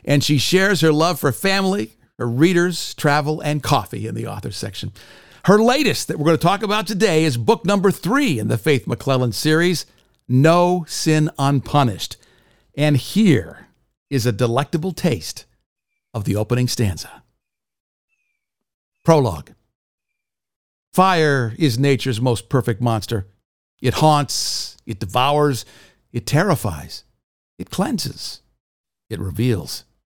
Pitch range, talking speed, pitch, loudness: 115-160 Hz, 130 wpm, 140 Hz, -19 LUFS